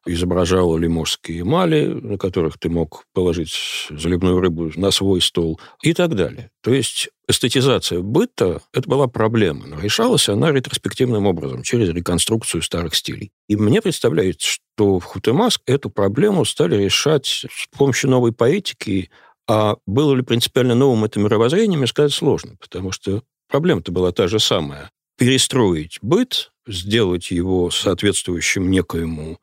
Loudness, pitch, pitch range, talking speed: -18 LUFS, 100 Hz, 90-125 Hz, 140 wpm